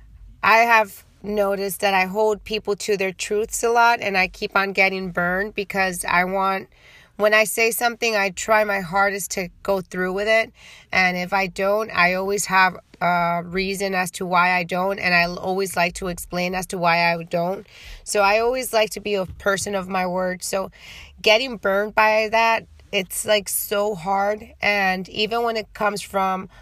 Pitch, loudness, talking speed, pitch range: 195 Hz, -20 LUFS, 190 wpm, 185-215 Hz